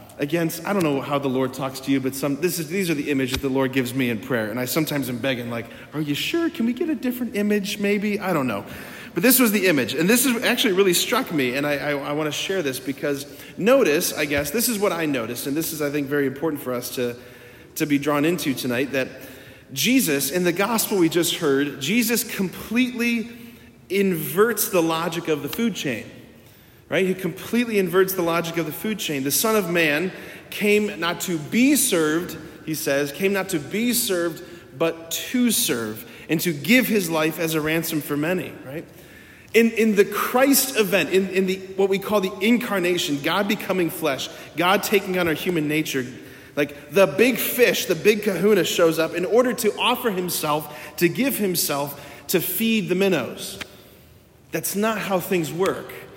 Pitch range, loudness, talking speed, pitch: 145-205 Hz, -22 LUFS, 205 wpm, 170 Hz